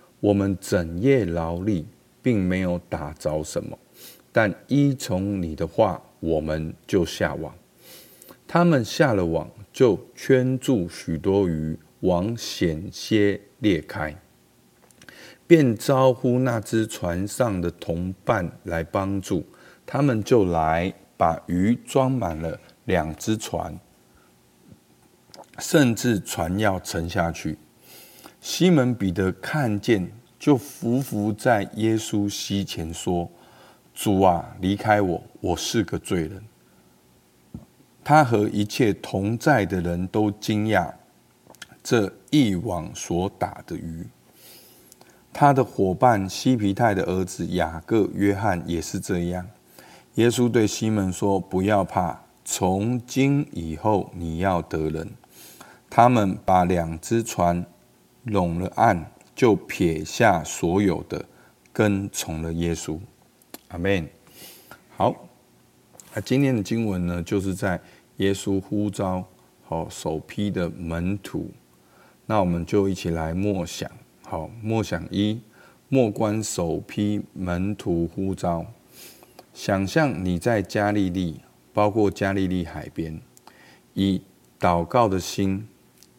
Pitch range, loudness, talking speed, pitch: 85-110 Hz, -24 LUFS, 160 characters per minute, 95 Hz